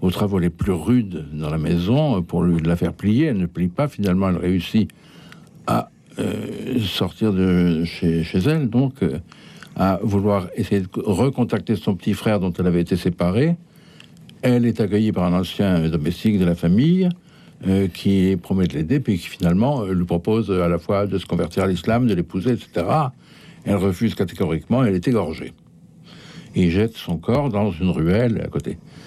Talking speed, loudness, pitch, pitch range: 180 wpm, -20 LUFS, 100 Hz, 90-120 Hz